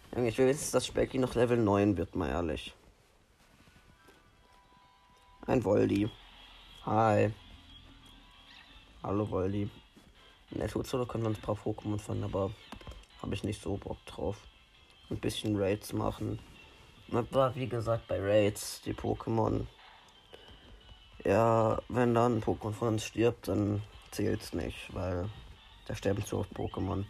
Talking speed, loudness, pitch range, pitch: 135 wpm, -32 LUFS, 100-115 Hz, 105 Hz